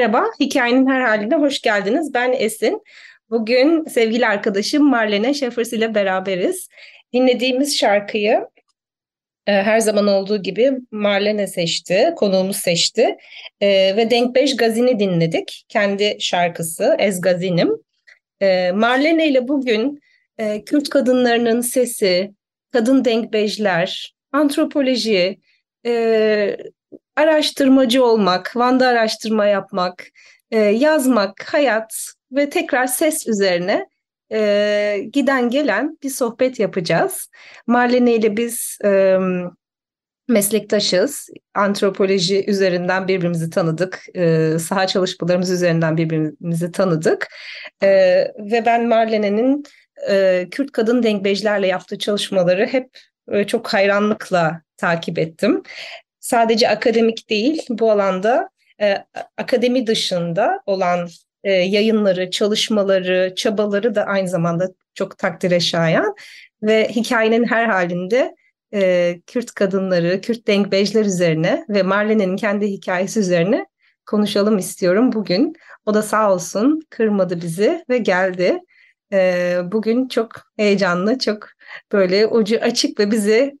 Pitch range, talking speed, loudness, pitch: 190-250 Hz, 110 wpm, -17 LUFS, 215 Hz